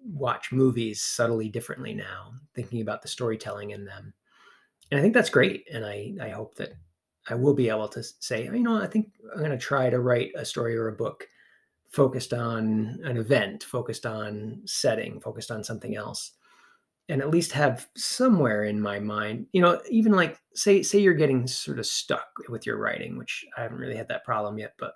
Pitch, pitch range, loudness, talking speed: 125 Hz, 110-150 Hz, -27 LUFS, 205 wpm